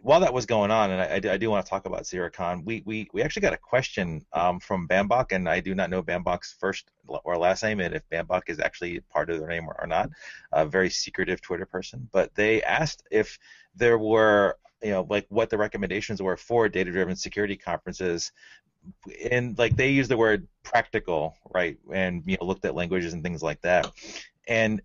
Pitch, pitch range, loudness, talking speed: 95 Hz, 90-110 Hz, -26 LUFS, 210 wpm